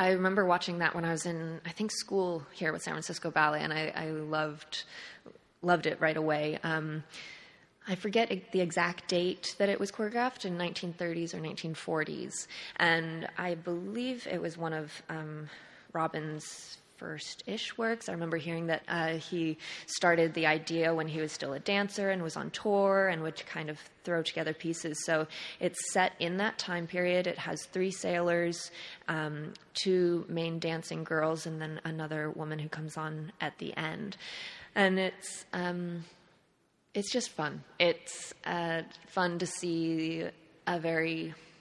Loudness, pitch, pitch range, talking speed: -33 LUFS, 170 Hz, 160-185 Hz, 165 wpm